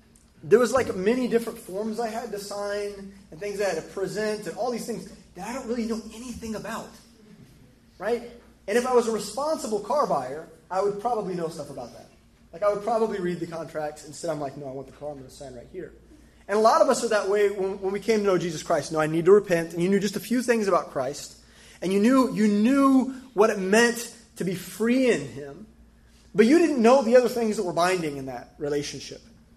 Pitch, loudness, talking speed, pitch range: 205 Hz, -25 LUFS, 250 wpm, 175-235 Hz